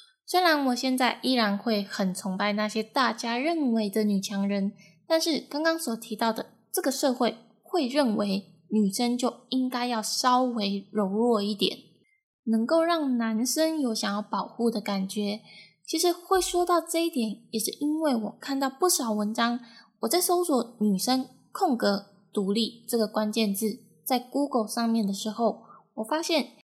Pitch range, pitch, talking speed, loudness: 210-280 Hz, 235 Hz, 245 characters per minute, -27 LUFS